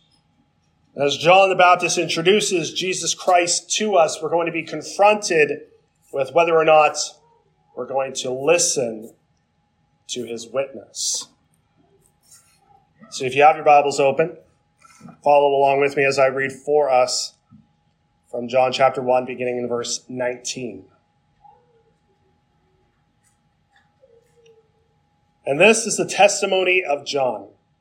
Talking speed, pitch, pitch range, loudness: 120 wpm, 155 Hz, 135-185 Hz, -18 LUFS